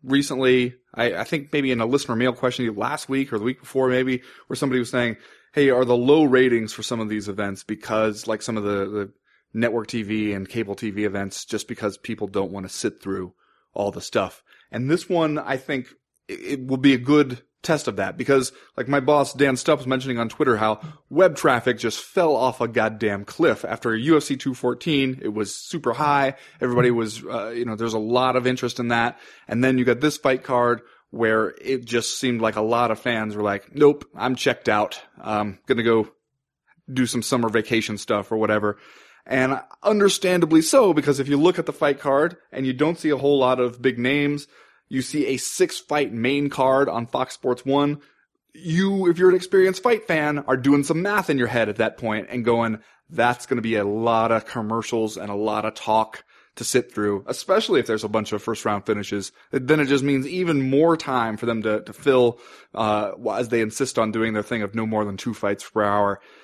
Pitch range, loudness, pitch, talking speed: 110-140 Hz, -22 LUFS, 125 Hz, 220 wpm